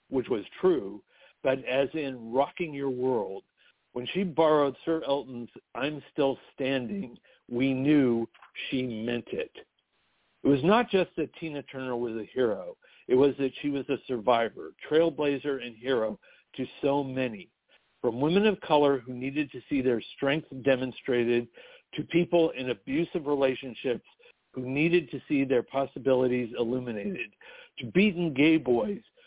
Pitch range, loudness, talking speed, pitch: 130-165 Hz, -28 LUFS, 150 wpm, 140 Hz